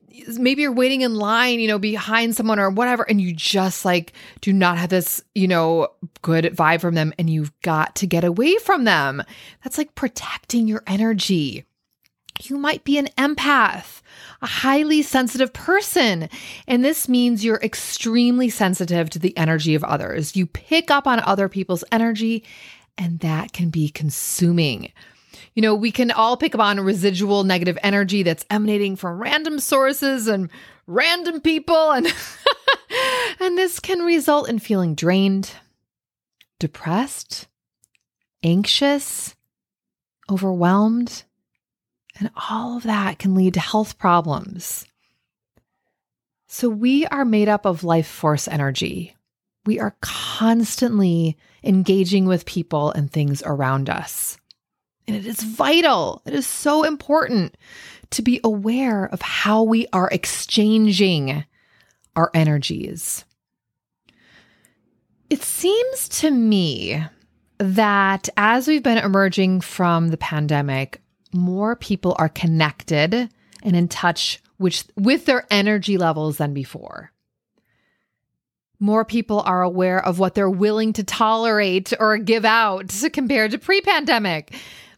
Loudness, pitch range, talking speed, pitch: -19 LUFS, 175-245 Hz, 135 wpm, 205 Hz